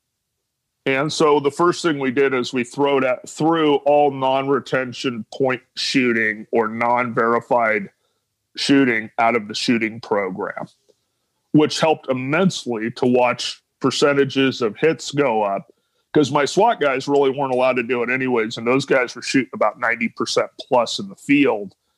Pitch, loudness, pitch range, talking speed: 130 Hz, -19 LUFS, 120-145 Hz, 155 wpm